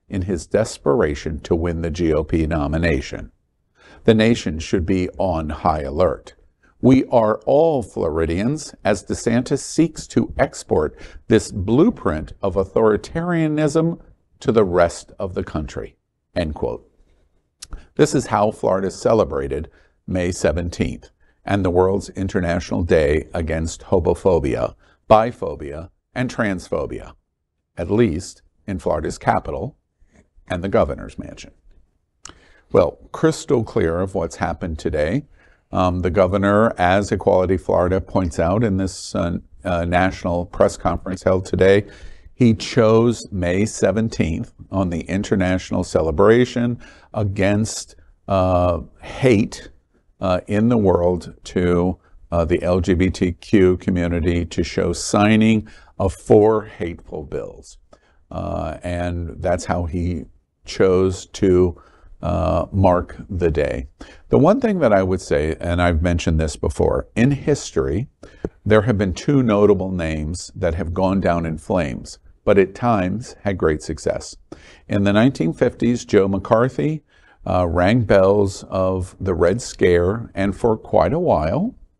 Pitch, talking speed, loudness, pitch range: 90 Hz, 125 wpm, -19 LUFS, 85-105 Hz